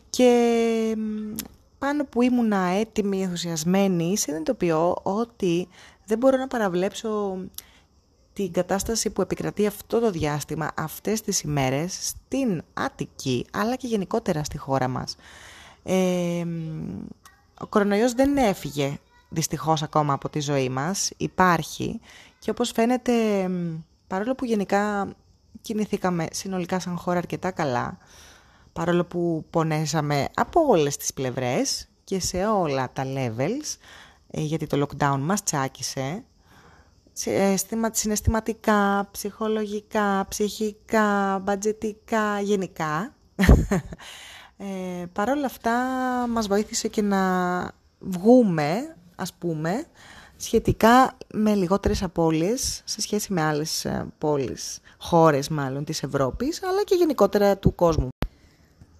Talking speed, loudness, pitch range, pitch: 105 wpm, -24 LUFS, 155-220 Hz, 190 Hz